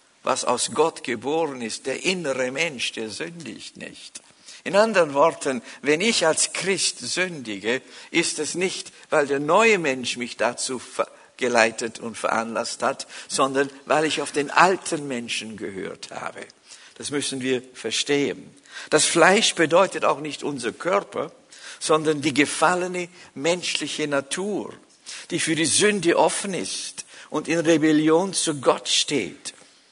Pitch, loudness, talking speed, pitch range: 155 Hz, -22 LUFS, 140 wpm, 135-170 Hz